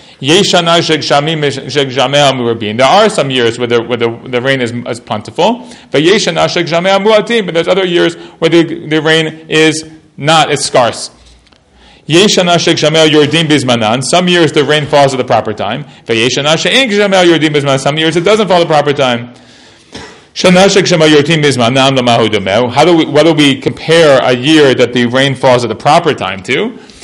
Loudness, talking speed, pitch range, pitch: -9 LUFS, 135 wpm, 130-170 Hz, 150 Hz